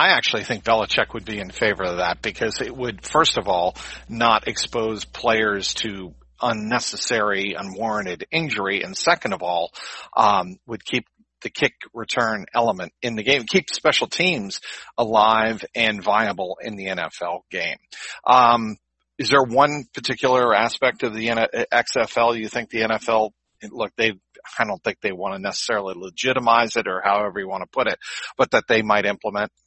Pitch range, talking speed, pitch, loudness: 105-130 Hz, 170 wpm, 115 Hz, -21 LUFS